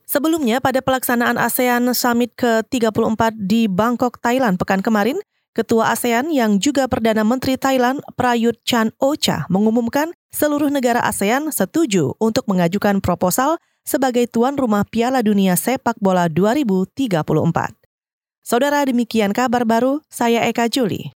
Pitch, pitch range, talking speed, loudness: 235 Hz, 215-260 Hz, 120 wpm, -18 LUFS